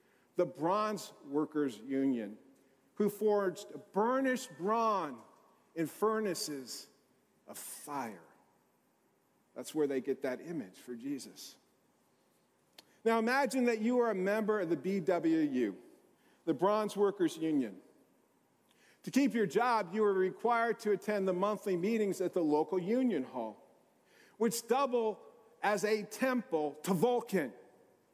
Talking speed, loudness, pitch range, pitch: 125 wpm, -34 LUFS, 165-230 Hz, 205 Hz